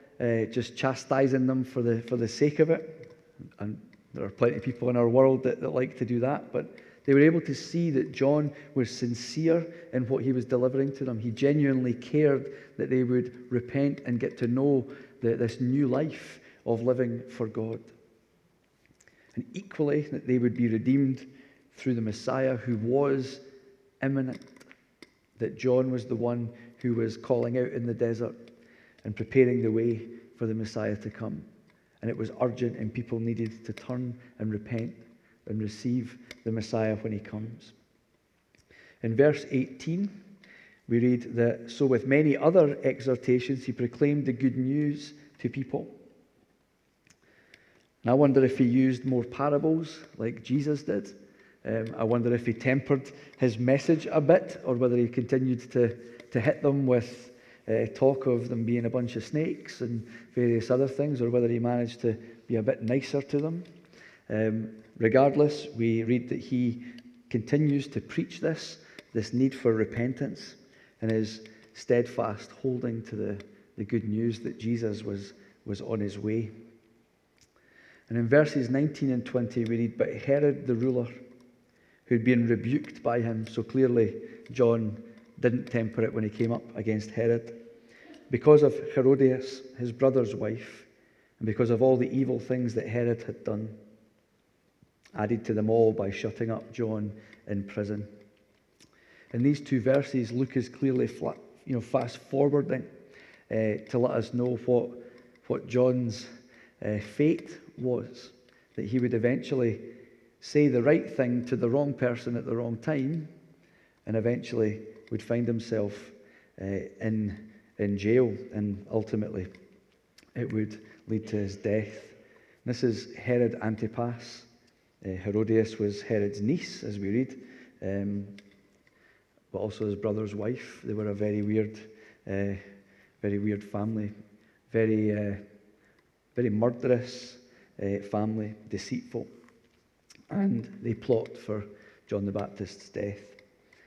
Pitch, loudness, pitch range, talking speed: 120 Hz, -28 LUFS, 110-130 Hz, 155 wpm